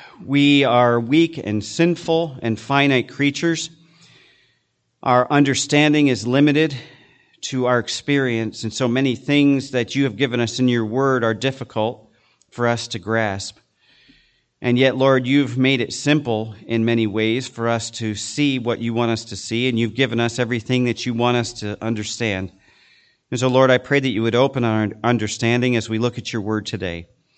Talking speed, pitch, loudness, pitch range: 180 wpm, 125 Hz, -19 LUFS, 115-135 Hz